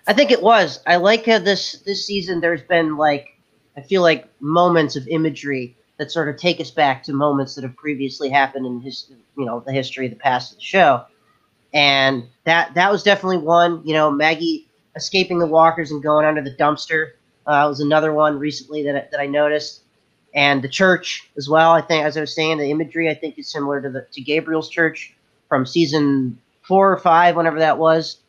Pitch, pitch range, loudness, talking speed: 155 Hz, 140-170 Hz, -18 LUFS, 210 wpm